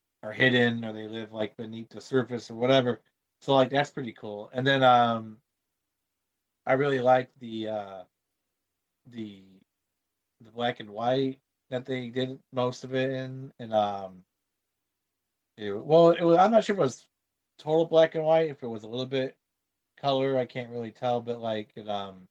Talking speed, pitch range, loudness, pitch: 180 wpm, 105-130 Hz, -27 LUFS, 120 Hz